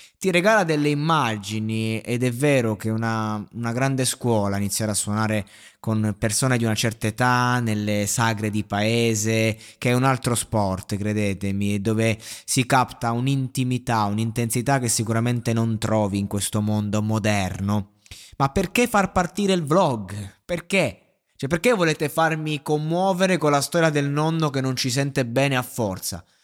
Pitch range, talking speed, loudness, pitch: 105-140 Hz, 155 wpm, -22 LUFS, 115 Hz